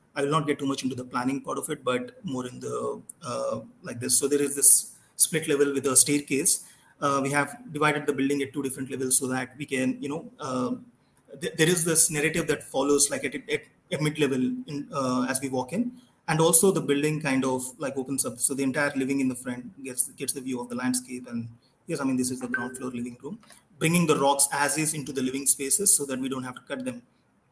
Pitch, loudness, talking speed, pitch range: 140 Hz, -23 LUFS, 245 wpm, 130-150 Hz